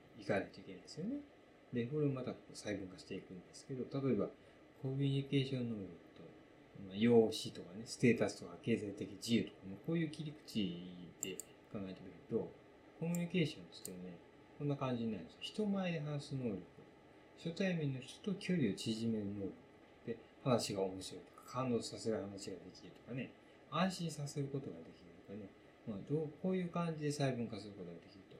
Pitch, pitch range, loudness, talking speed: 130 Hz, 105-150 Hz, -41 LUFS, 380 characters per minute